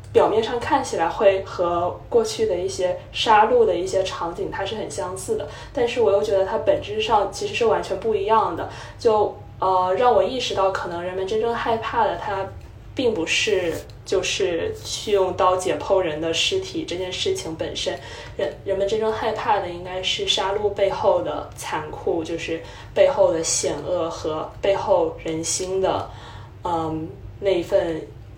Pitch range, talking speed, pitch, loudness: 180-290 Hz, 245 characters per minute, 195 Hz, -22 LUFS